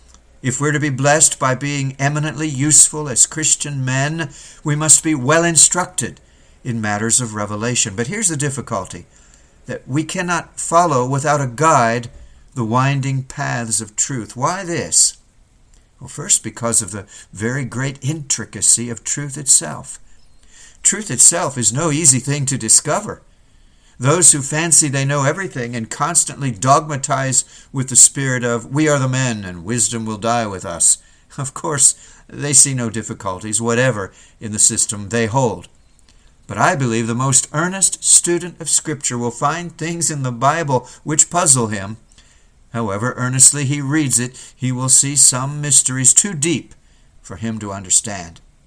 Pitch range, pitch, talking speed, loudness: 115-150 Hz, 130 Hz, 155 wpm, -15 LUFS